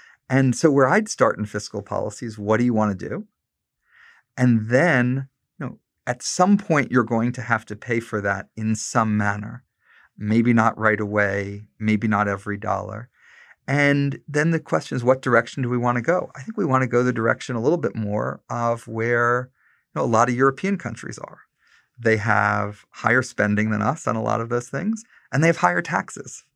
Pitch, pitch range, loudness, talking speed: 120 Hz, 110-135 Hz, -22 LUFS, 210 wpm